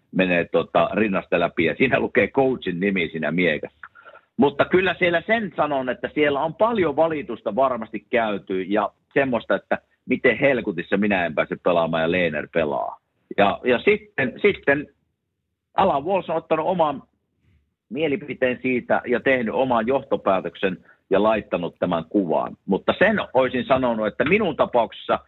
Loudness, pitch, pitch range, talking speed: -22 LUFS, 130 Hz, 100-160 Hz, 140 wpm